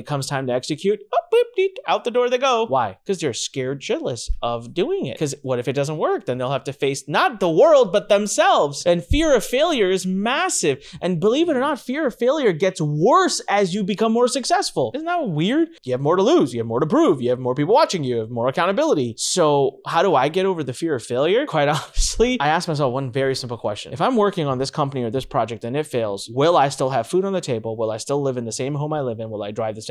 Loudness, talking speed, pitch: -20 LUFS, 275 wpm, 155 Hz